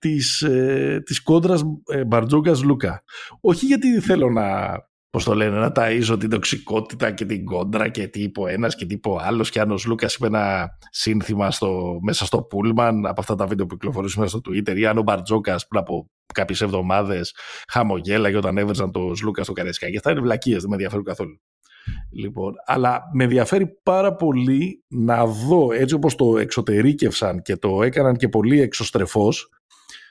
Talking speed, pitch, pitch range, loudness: 175 wpm, 110 Hz, 100-130 Hz, -21 LUFS